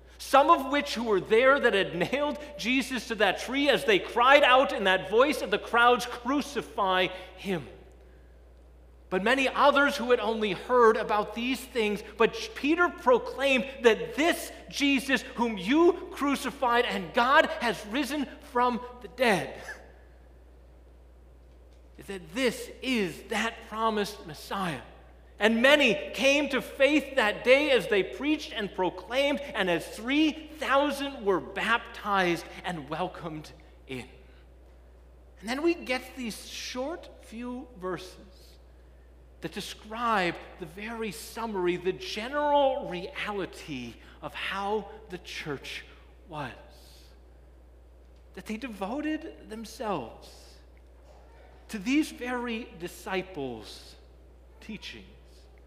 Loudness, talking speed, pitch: -27 LUFS, 115 wpm, 220 Hz